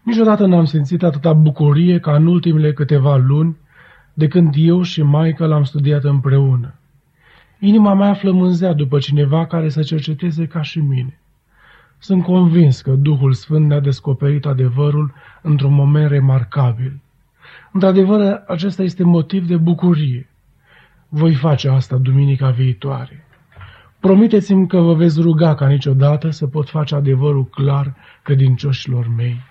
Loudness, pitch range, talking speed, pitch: -14 LUFS, 140-170 Hz, 135 wpm, 150 Hz